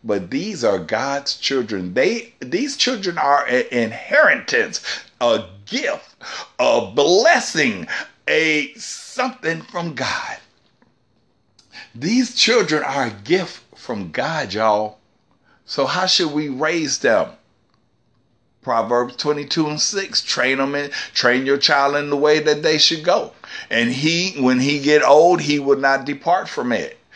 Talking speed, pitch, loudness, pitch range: 135 wpm, 145 Hz, -18 LUFS, 125-165 Hz